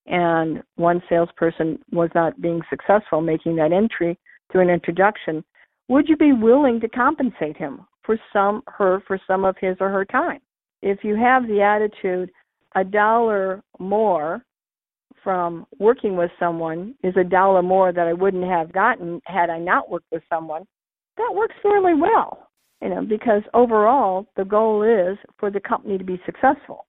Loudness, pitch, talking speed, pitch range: -20 LUFS, 190 Hz, 165 wpm, 170-220 Hz